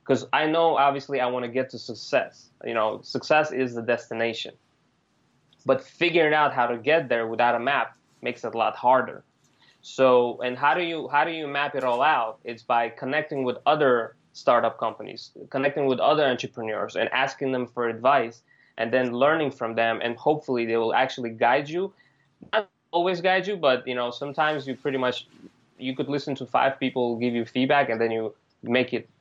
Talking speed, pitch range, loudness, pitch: 195 wpm, 120-145 Hz, -24 LUFS, 130 Hz